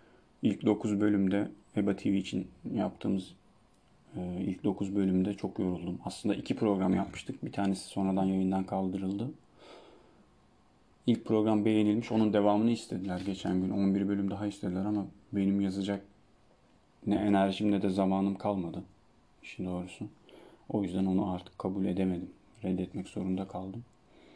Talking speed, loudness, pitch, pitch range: 130 wpm, -32 LUFS, 100 Hz, 95-105 Hz